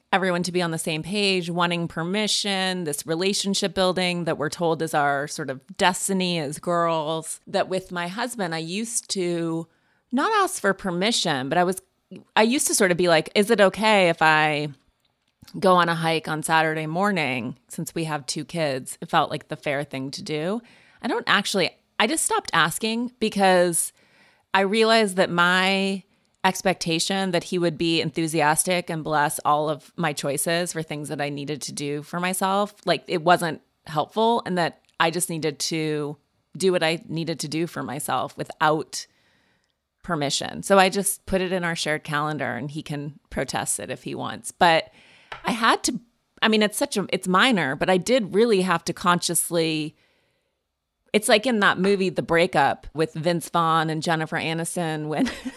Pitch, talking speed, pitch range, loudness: 175 Hz, 185 wpm, 155-195 Hz, -23 LUFS